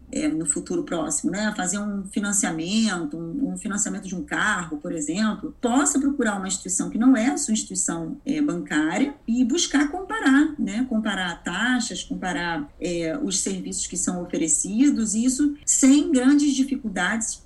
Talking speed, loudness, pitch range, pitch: 155 wpm, -23 LUFS, 185-275 Hz, 230 Hz